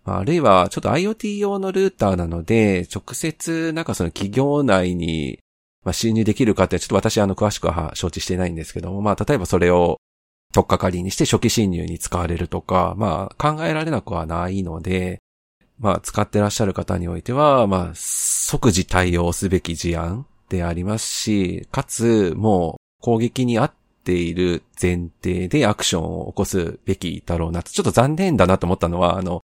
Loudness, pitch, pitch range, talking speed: -20 LUFS, 95 Hz, 85-115 Hz, 370 characters per minute